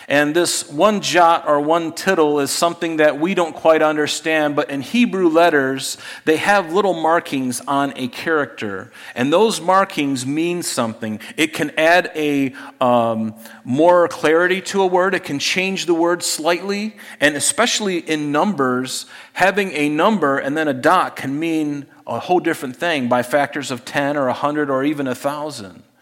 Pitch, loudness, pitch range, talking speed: 155 Hz, -18 LUFS, 140-175 Hz, 170 wpm